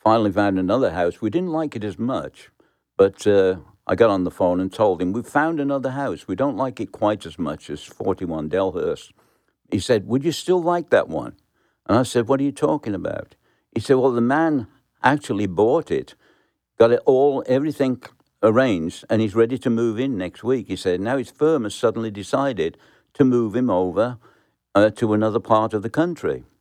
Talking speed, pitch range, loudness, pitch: 205 wpm, 105-140 Hz, -21 LUFS, 120 Hz